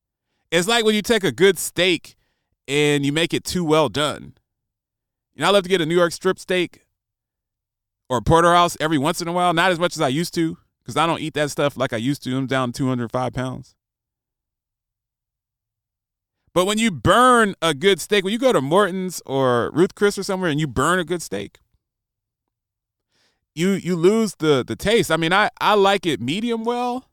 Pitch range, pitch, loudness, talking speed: 125-185 Hz, 160 Hz, -19 LUFS, 205 wpm